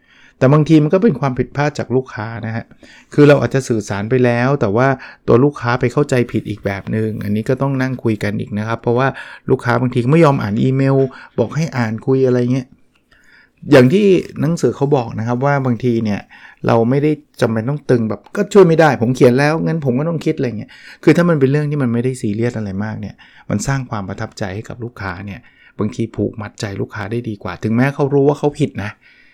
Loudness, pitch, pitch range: -16 LUFS, 125 Hz, 110-140 Hz